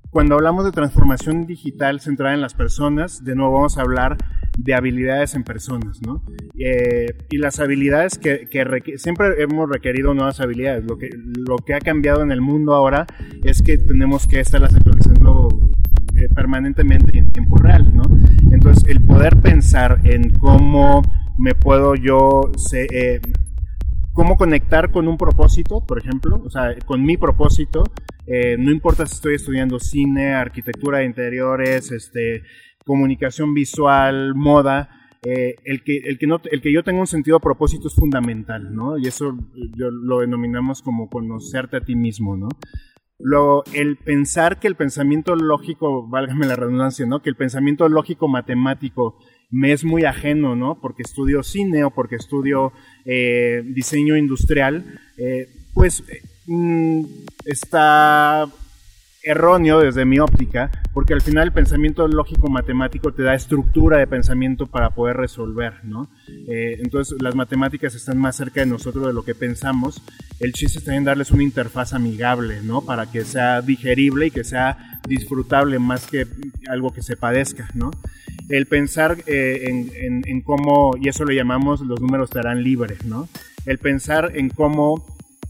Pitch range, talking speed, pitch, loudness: 120-145 Hz, 160 wpm, 130 Hz, -17 LUFS